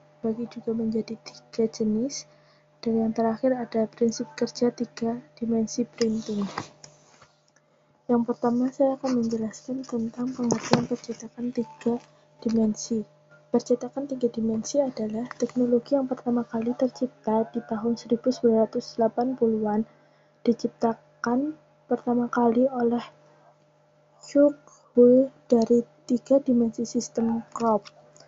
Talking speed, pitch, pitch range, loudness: 100 wpm, 235 Hz, 225-245 Hz, -26 LUFS